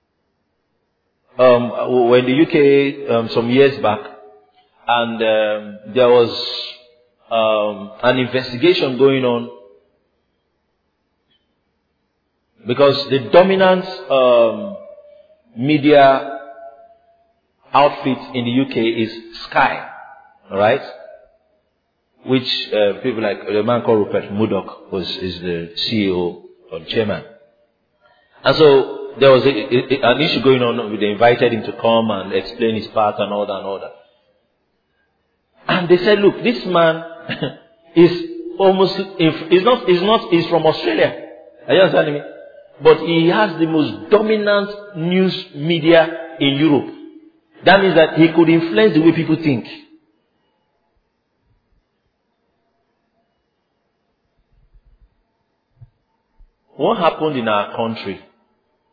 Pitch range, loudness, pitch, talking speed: 115-185 Hz, -16 LUFS, 140 Hz, 120 wpm